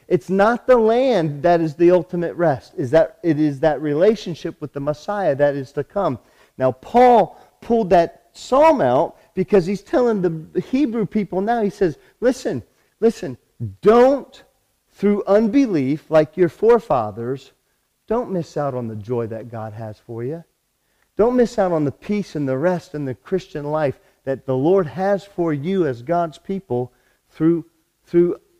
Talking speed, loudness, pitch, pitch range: 165 wpm, -19 LUFS, 175 Hz, 145-205 Hz